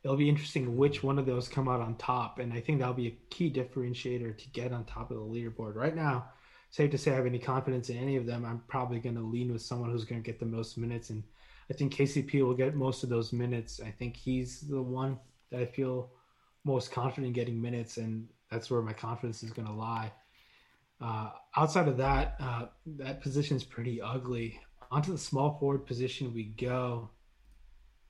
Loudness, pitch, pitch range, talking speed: -34 LUFS, 125 Hz, 115-135 Hz, 215 wpm